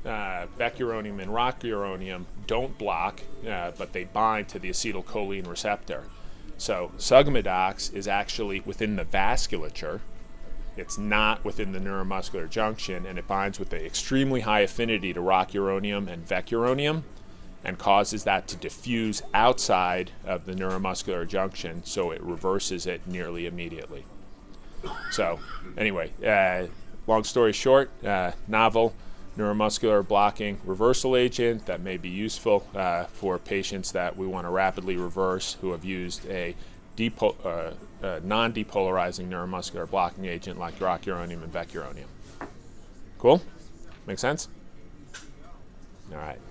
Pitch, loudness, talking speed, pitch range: 95 Hz, -27 LUFS, 130 wpm, 90-105 Hz